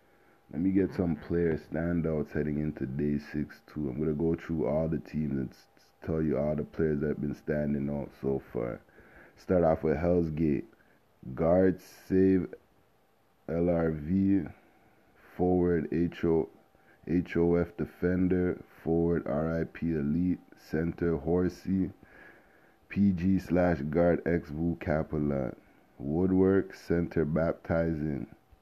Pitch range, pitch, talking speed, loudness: 75-90 Hz, 80 Hz, 115 wpm, -30 LUFS